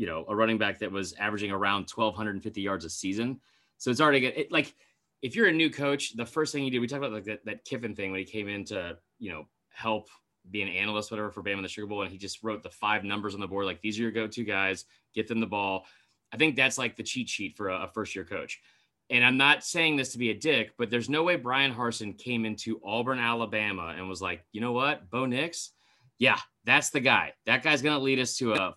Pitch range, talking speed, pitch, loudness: 100-125 Hz, 265 wpm, 110 Hz, -28 LUFS